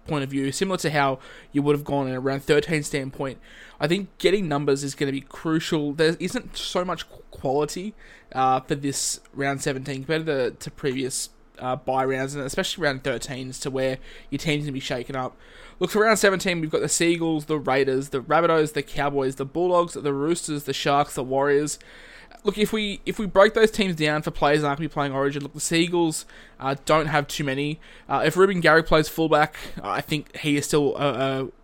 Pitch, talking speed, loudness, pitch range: 145 Hz, 220 wpm, -24 LUFS, 135-165 Hz